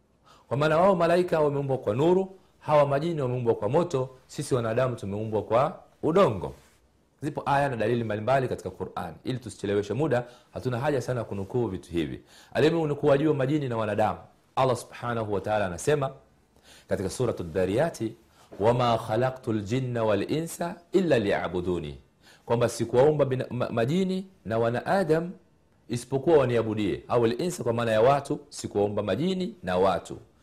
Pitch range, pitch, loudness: 105-150 Hz, 120 Hz, -27 LUFS